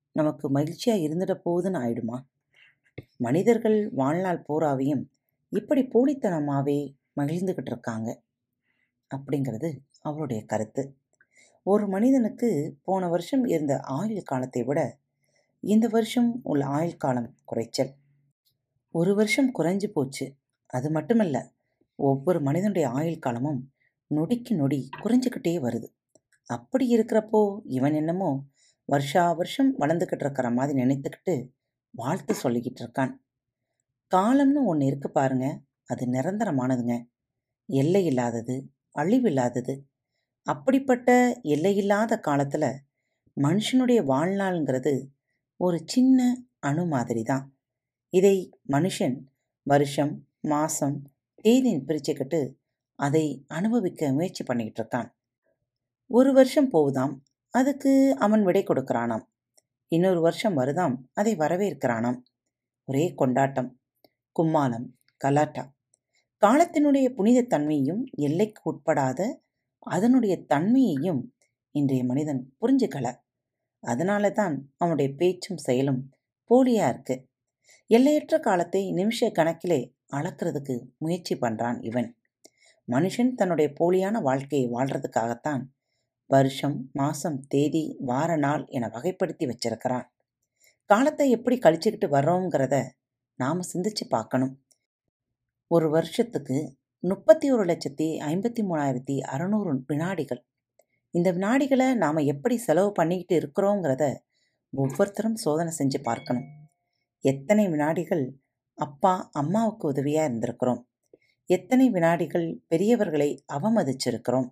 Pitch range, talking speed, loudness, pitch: 130-195 Hz, 95 wpm, -25 LUFS, 150 Hz